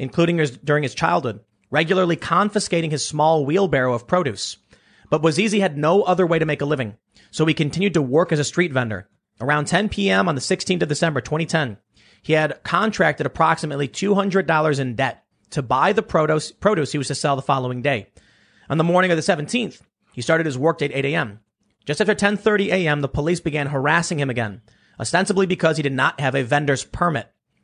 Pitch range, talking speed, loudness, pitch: 135-175 Hz, 200 wpm, -20 LUFS, 155 Hz